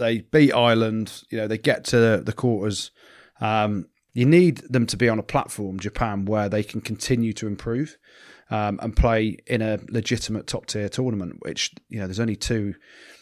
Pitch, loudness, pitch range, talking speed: 110 Hz, -23 LUFS, 105-120 Hz, 185 wpm